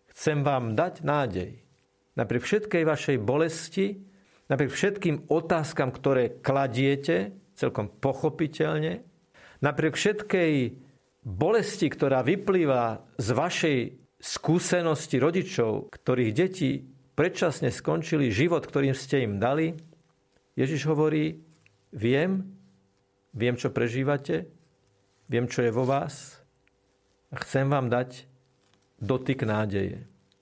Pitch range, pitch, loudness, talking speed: 125-160 Hz, 140 Hz, -27 LUFS, 100 wpm